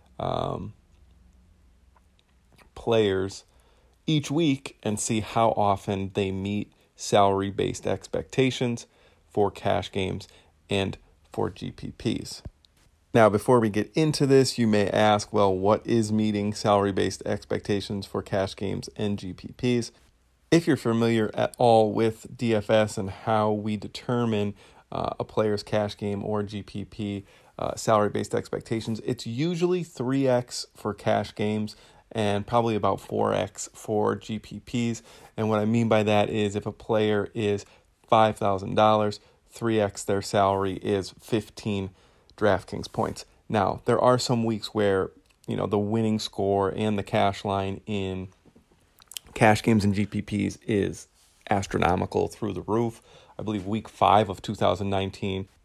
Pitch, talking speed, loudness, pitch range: 105 Hz, 135 wpm, -26 LUFS, 100-115 Hz